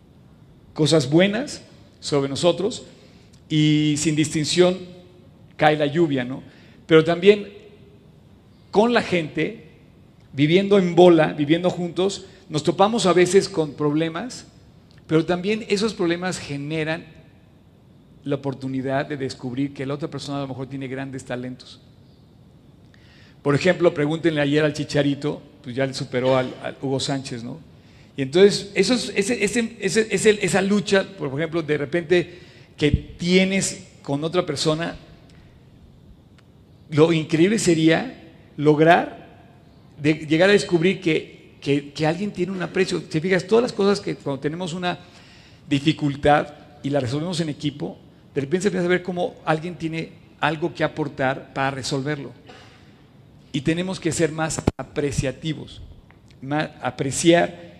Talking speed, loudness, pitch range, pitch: 135 wpm, -21 LUFS, 140-180 Hz, 160 Hz